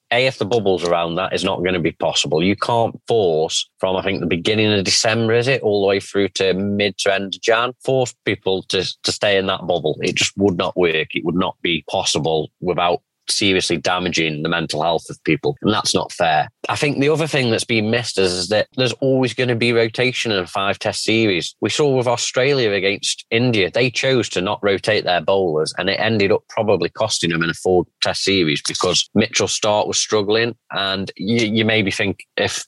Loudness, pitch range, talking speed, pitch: -18 LUFS, 95-120 Hz, 220 wpm, 105 Hz